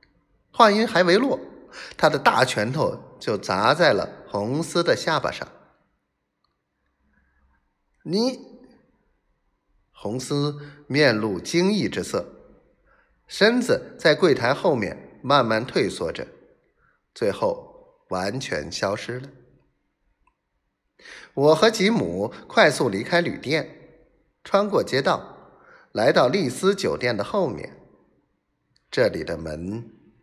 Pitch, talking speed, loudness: 170 Hz, 150 characters per minute, -22 LUFS